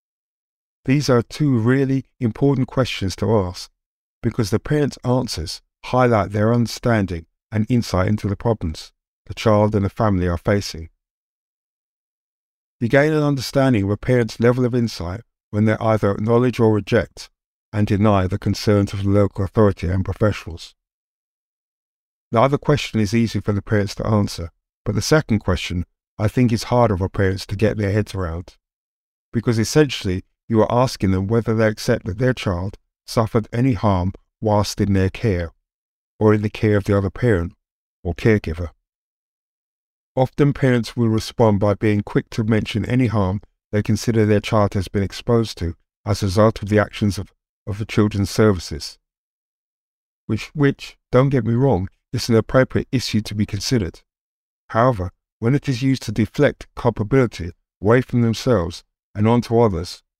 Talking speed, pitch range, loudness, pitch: 165 wpm, 100-120 Hz, -20 LUFS, 110 Hz